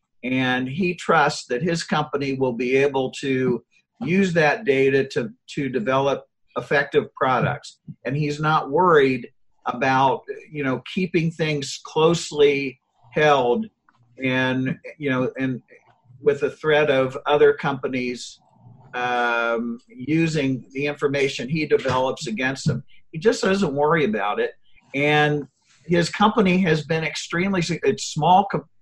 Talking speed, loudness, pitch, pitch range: 130 wpm, -21 LUFS, 145 Hz, 130-165 Hz